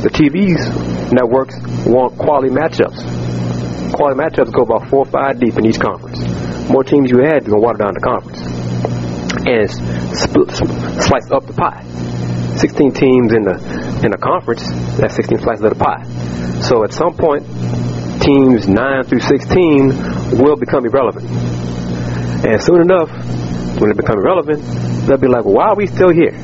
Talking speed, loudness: 165 wpm, -14 LUFS